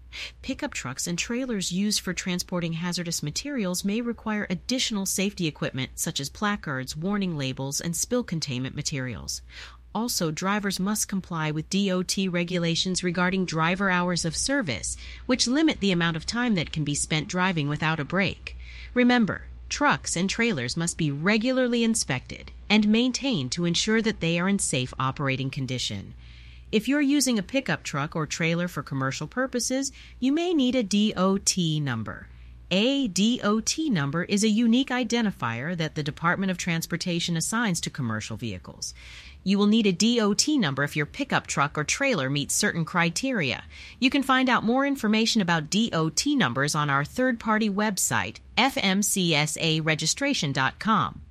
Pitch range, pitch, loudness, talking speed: 150-220 Hz, 180 Hz, -25 LUFS, 150 wpm